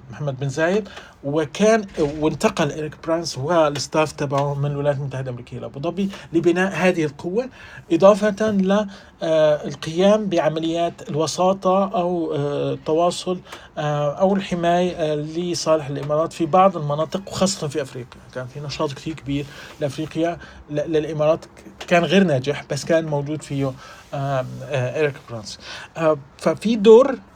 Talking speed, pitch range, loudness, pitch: 115 wpm, 145-180 Hz, -21 LUFS, 155 Hz